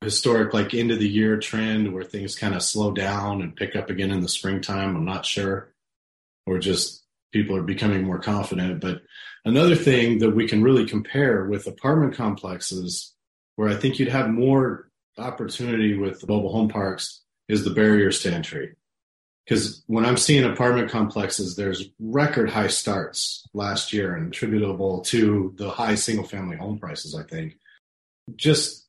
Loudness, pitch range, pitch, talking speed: -23 LUFS, 95-115 Hz, 105 Hz, 170 wpm